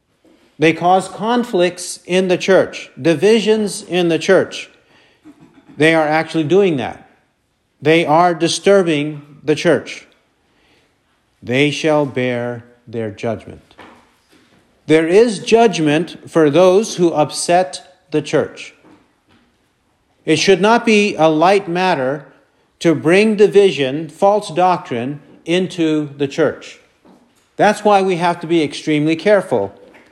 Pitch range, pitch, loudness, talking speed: 150-190 Hz, 170 Hz, -15 LUFS, 115 wpm